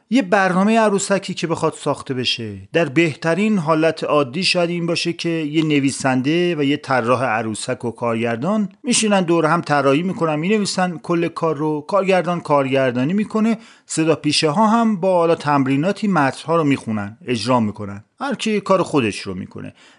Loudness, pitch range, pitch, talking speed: -18 LUFS, 135-190 Hz, 165 Hz, 165 wpm